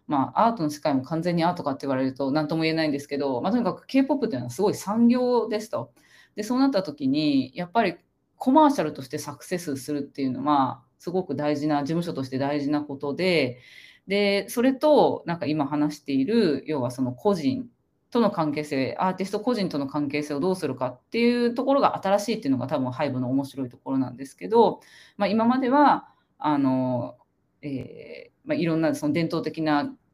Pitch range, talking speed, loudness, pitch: 140-225 Hz, 415 characters per minute, -25 LUFS, 155 Hz